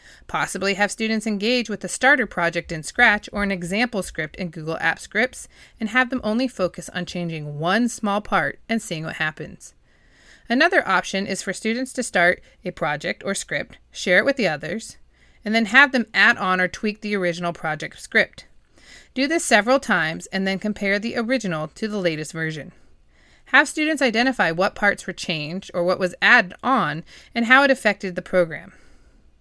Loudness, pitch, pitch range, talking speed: -21 LUFS, 195 Hz, 175-230 Hz, 185 wpm